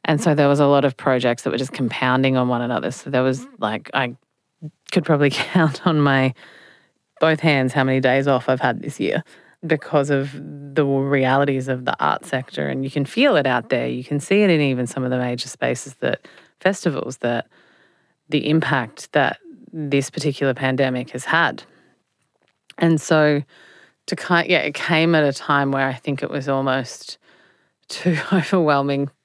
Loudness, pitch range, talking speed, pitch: -20 LUFS, 130-155 Hz, 185 wpm, 140 Hz